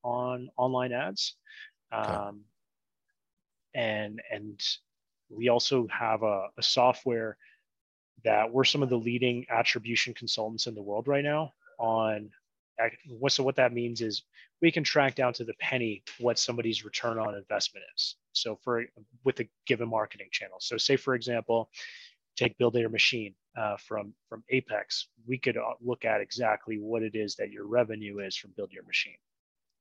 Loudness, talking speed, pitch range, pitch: -30 LUFS, 160 wpm, 110-125 Hz, 120 Hz